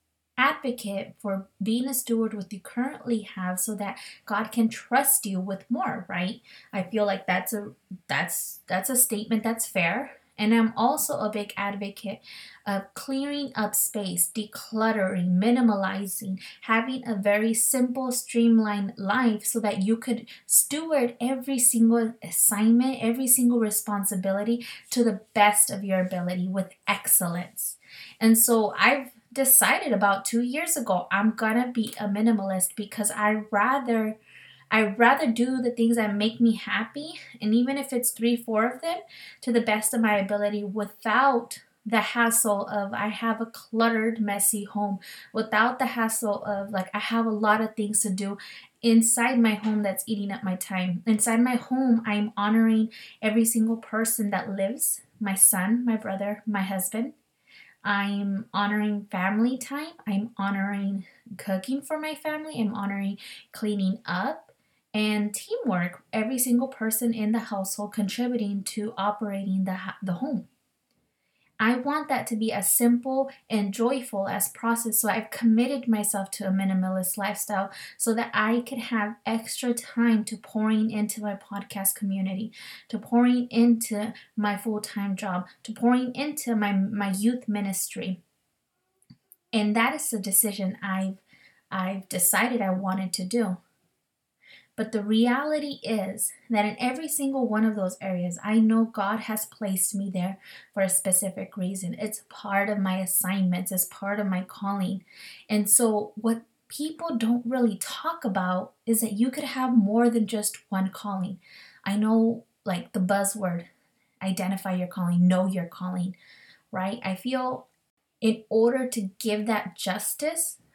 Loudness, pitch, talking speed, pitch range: -25 LUFS, 215 Hz, 155 wpm, 195-235 Hz